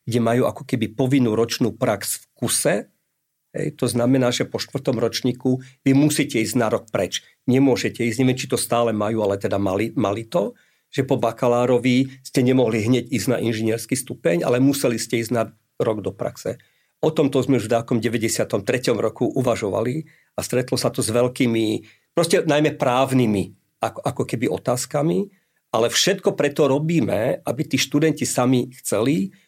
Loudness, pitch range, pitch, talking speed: -21 LUFS, 115-135 Hz, 125 Hz, 170 wpm